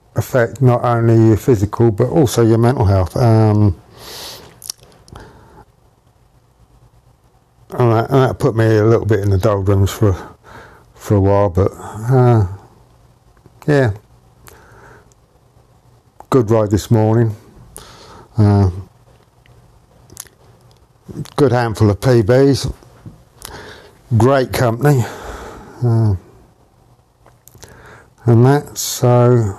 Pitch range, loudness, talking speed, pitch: 105-125 Hz, -14 LUFS, 95 wpm, 115 Hz